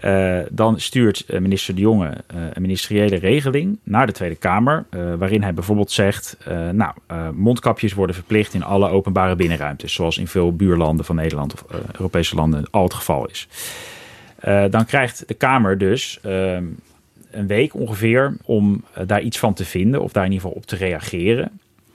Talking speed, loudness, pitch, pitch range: 185 wpm, -19 LUFS, 95 Hz, 90-110 Hz